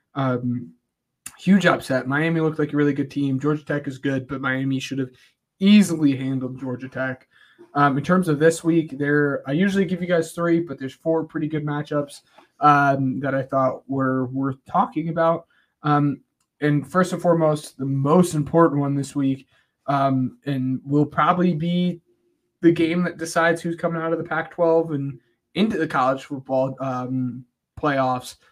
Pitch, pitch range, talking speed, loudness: 145 Hz, 135-165 Hz, 175 wpm, -22 LUFS